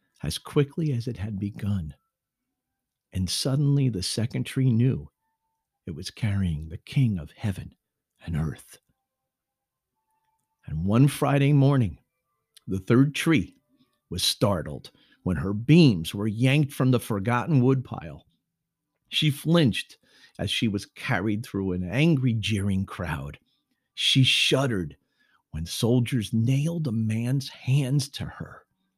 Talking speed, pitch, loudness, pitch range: 125 wpm, 125 Hz, -25 LUFS, 100-145 Hz